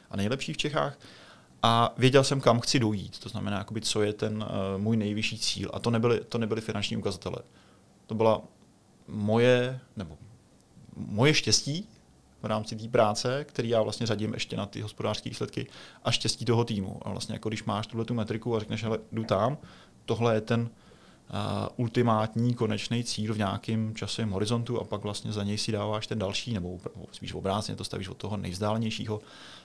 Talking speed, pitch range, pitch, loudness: 185 wpm, 105-115 Hz, 110 Hz, -29 LUFS